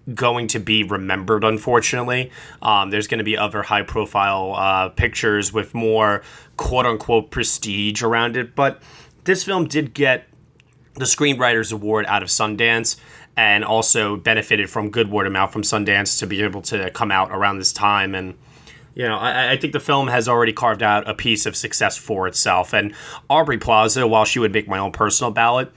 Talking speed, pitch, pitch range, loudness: 185 wpm, 110 Hz, 105-125 Hz, -18 LUFS